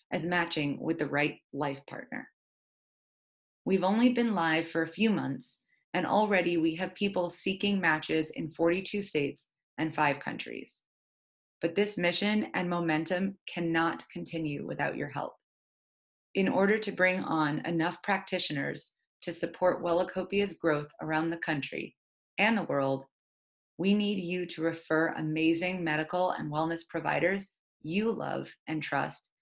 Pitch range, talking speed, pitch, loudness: 155-185 Hz, 140 wpm, 170 Hz, -31 LUFS